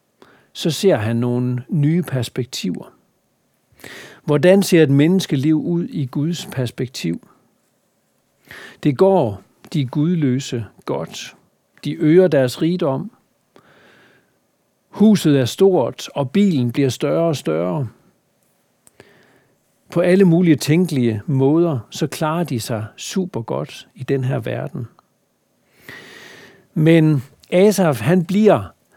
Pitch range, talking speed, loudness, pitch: 130-180 Hz, 105 wpm, -18 LUFS, 155 Hz